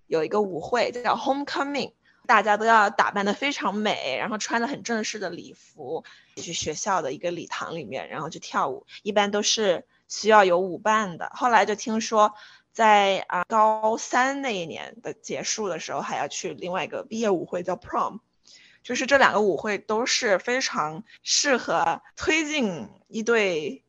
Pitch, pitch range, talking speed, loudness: 215 Hz, 195-235 Hz, 280 characters per minute, -24 LUFS